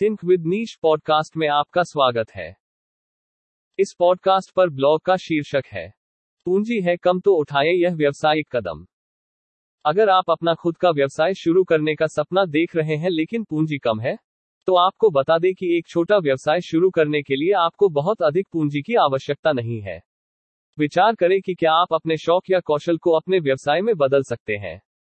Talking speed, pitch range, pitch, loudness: 180 wpm, 145-180 Hz, 160 Hz, -20 LUFS